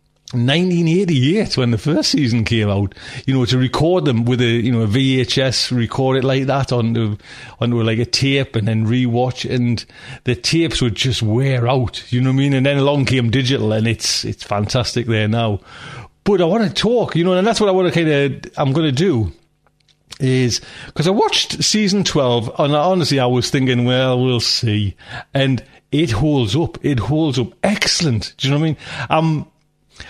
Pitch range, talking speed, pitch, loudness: 120-150 Hz, 205 wpm, 130 Hz, -17 LUFS